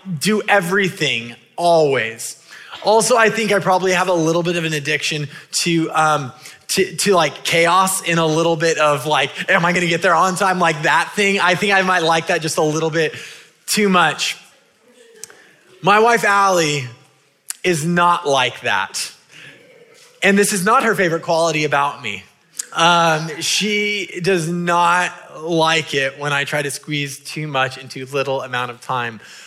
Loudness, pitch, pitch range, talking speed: -16 LUFS, 170 Hz, 150-190 Hz, 170 wpm